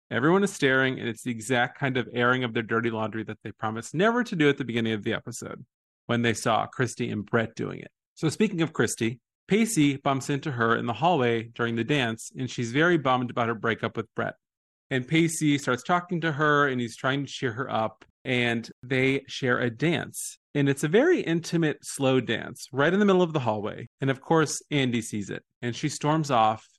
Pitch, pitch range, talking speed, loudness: 130 Hz, 115-150 Hz, 220 wpm, -26 LUFS